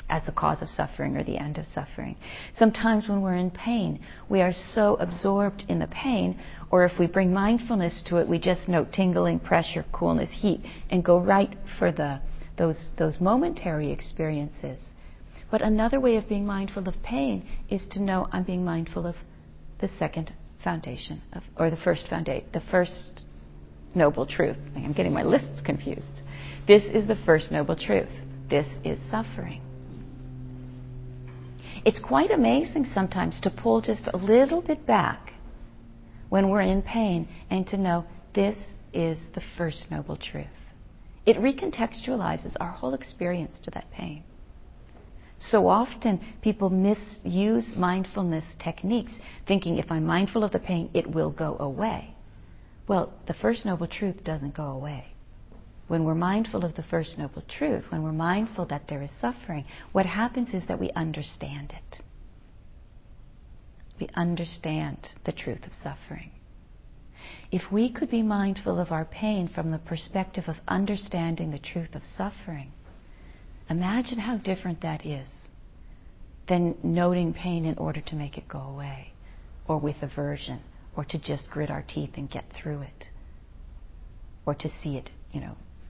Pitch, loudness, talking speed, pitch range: 170 Hz, -27 LUFS, 155 wpm, 140-195 Hz